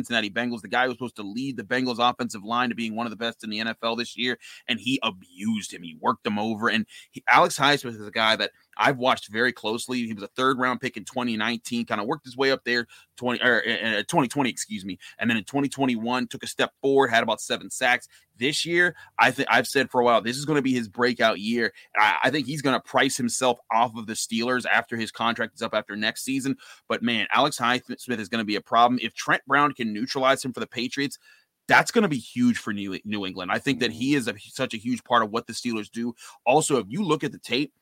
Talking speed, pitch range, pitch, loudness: 260 wpm, 115-130 Hz, 120 Hz, -24 LUFS